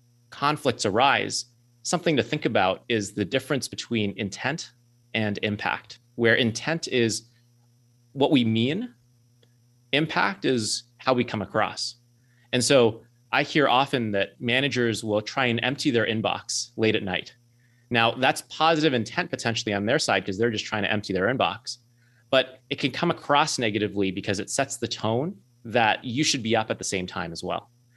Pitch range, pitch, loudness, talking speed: 110-130 Hz, 120 Hz, -25 LUFS, 170 wpm